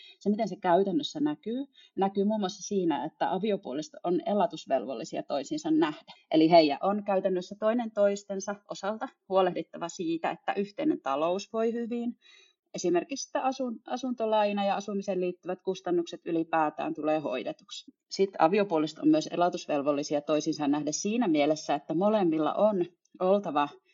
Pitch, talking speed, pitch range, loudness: 200 Hz, 130 wpm, 170-250 Hz, -29 LUFS